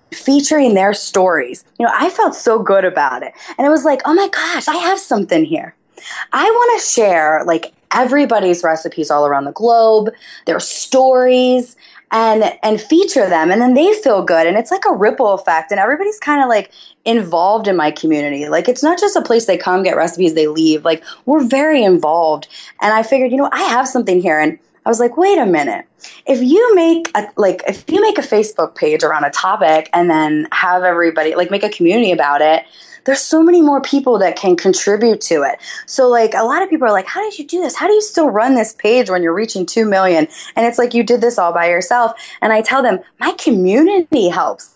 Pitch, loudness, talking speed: 230 Hz, -13 LUFS, 225 wpm